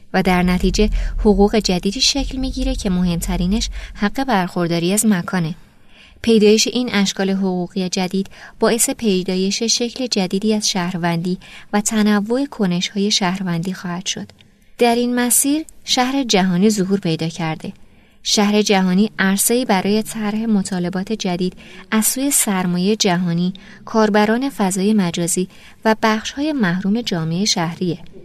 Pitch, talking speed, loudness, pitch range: 200 Hz, 125 wpm, -18 LUFS, 185-220 Hz